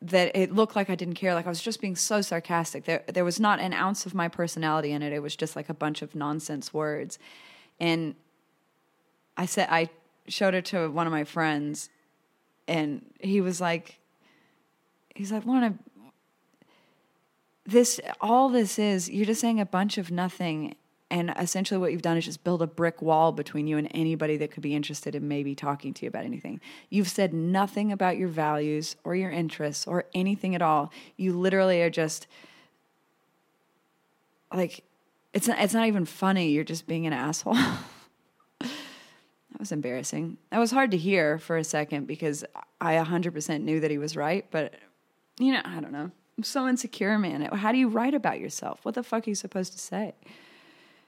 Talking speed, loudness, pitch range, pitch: 185 wpm, -28 LUFS, 155-195 Hz, 170 Hz